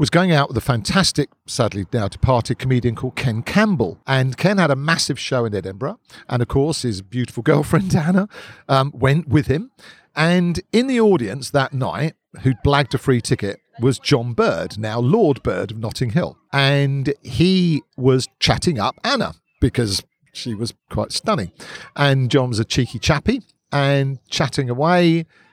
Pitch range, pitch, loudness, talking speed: 125-160 Hz, 135 Hz, -19 LUFS, 165 wpm